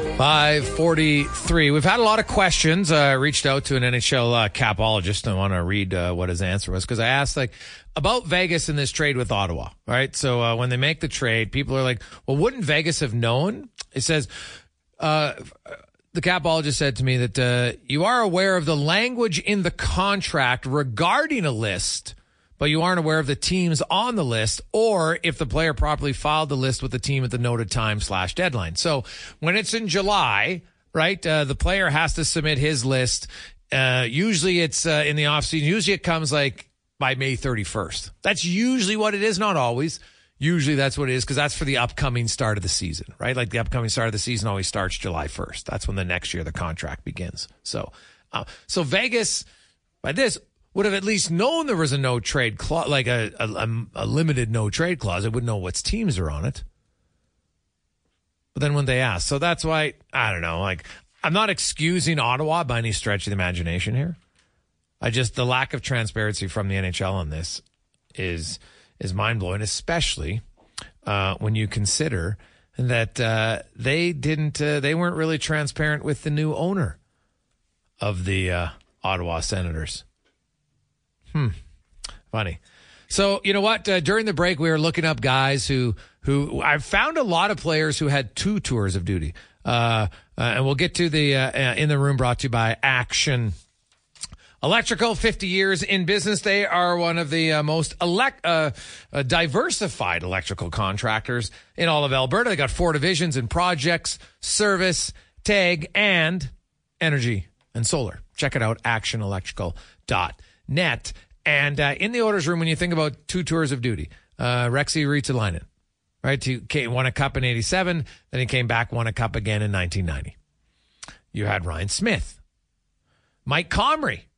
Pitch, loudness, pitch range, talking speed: 135 Hz, -22 LUFS, 105-165 Hz, 190 wpm